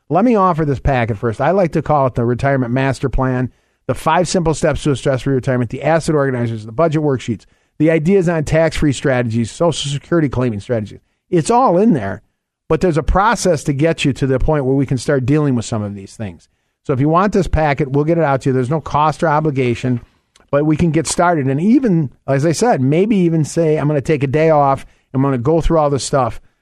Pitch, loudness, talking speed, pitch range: 145 Hz, -16 LUFS, 245 wpm, 130-165 Hz